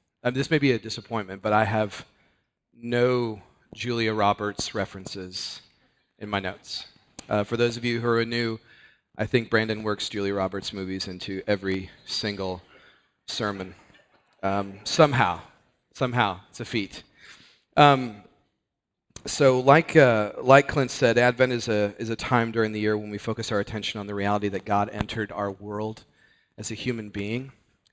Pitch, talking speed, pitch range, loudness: 110 Hz, 160 wpm, 100-120 Hz, -25 LUFS